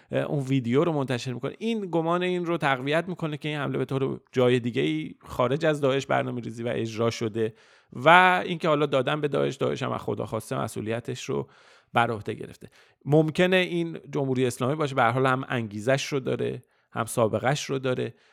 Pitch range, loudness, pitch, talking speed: 125-160 Hz, -26 LUFS, 135 Hz, 185 wpm